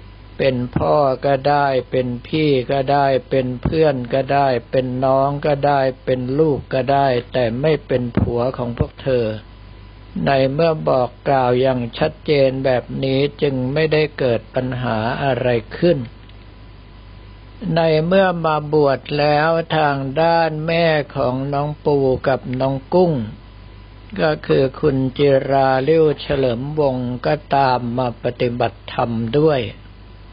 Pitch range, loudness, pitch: 120-145 Hz, -18 LUFS, 135 Hz